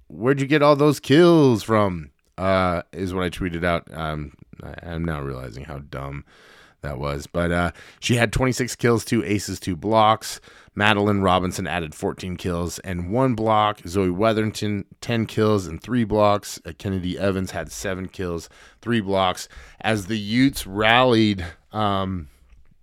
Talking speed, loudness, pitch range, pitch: 155 wpm, -22 LUFS, 85-110 Hz, 95 Hz